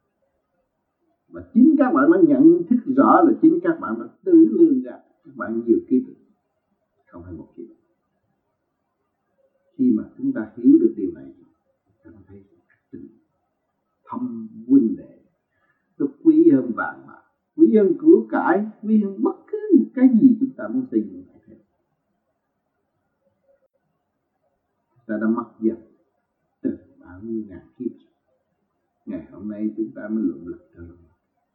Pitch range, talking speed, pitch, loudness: 225-320 Hz, 145 wpm, 275 Hz, -19 LUFS